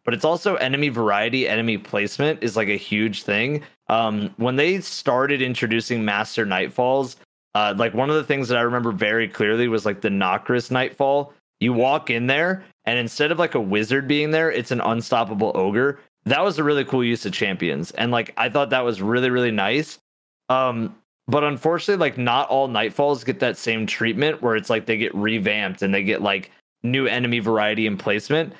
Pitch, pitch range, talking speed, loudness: 125 Hz, 110-140 Hz, 195 wpm, -21 LUFS